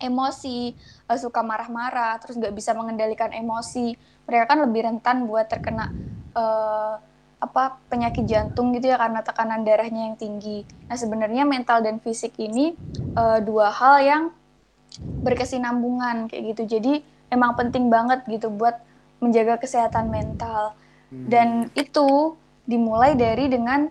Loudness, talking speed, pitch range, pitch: -22 LUFS, 130 wpm, 225-250 Hz, 235 Hz